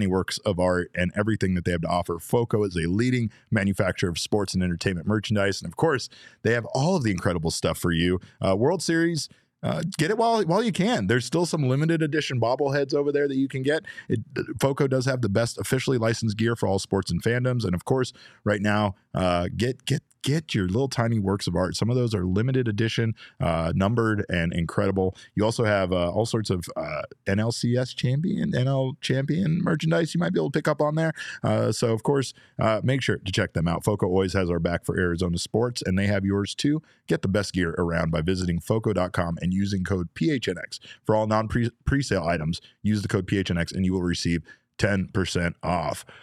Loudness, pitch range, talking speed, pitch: -25 LUFS, 95-130 Hz, 215 wpm, 110 Hz